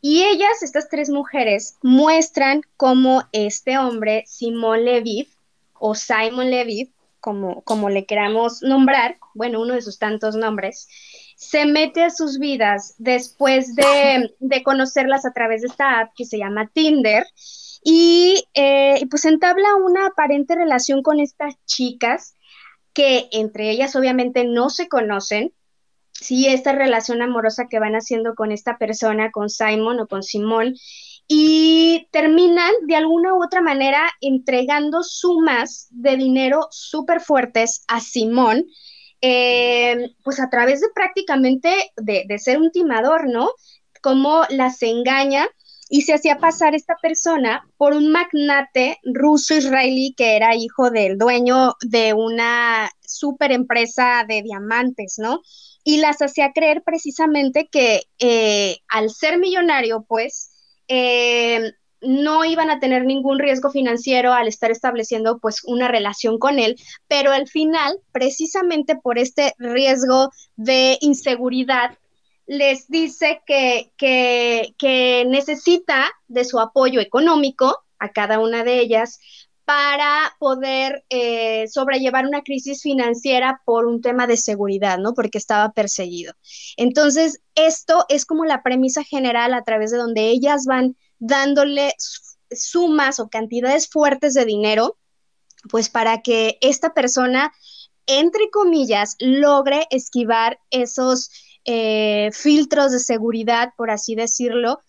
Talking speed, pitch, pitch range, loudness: 135 wpm, 260 Hz, 230-295 Hz, -17 LUFS